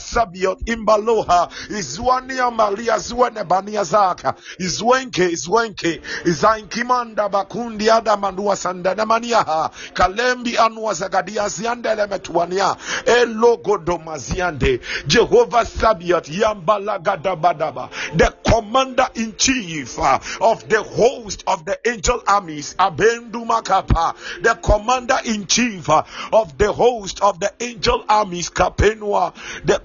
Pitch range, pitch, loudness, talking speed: 185-235 Hz, 215 Hz, -18 LUFS, 100 wpm